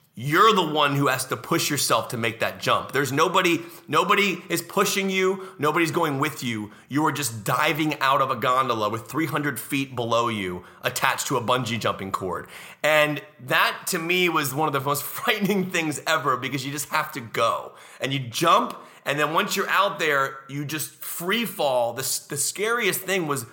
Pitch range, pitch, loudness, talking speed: 135-170 Hz, 150 Hz, -23 LUFS, 195 wpm